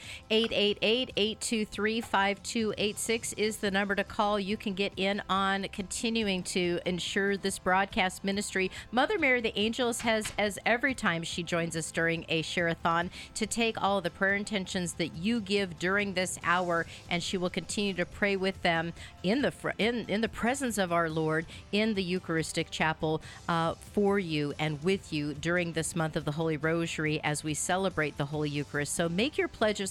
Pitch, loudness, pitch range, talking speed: 190 Hz, -30 LUFS, 165-210 Hz, 185 wpm